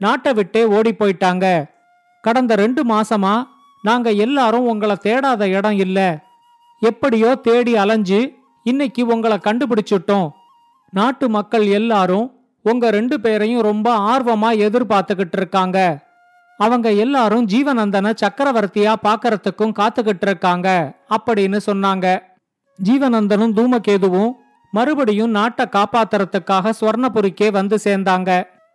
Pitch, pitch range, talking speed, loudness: 220 Hz, 200-240 Hz, 95 wpm, -16 LUFS